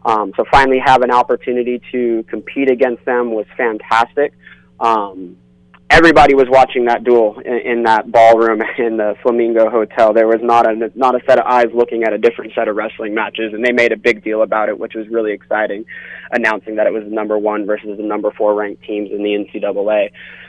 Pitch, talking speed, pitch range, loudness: 115 Hz, 205 wpm, 105-120 Hz, -14 LUFS